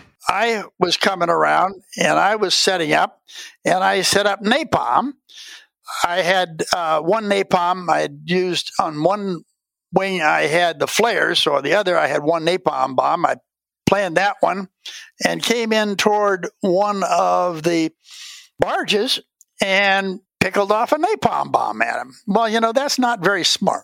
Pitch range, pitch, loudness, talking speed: 175-225 Hz, 195 Hz, -18 LUFS, 165 wpm